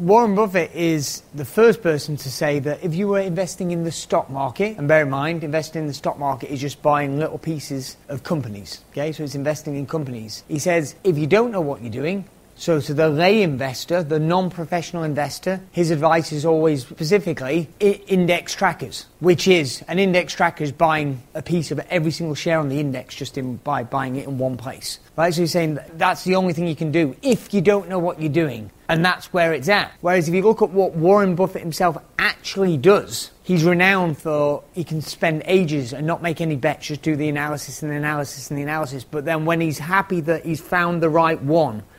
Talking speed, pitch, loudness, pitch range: 225 wpm, 160 Hz, -20 LUFS, 145-180 Hz